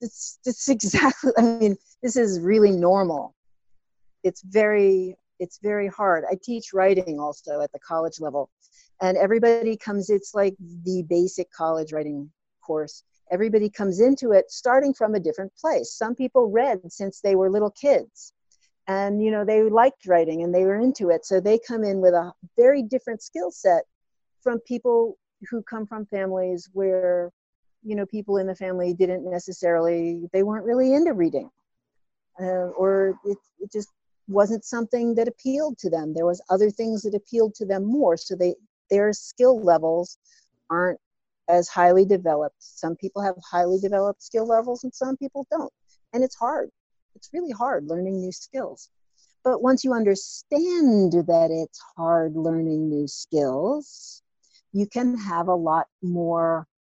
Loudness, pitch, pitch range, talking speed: -23 LUFS, 200 Hz, 175-230 Hz, 165 wpm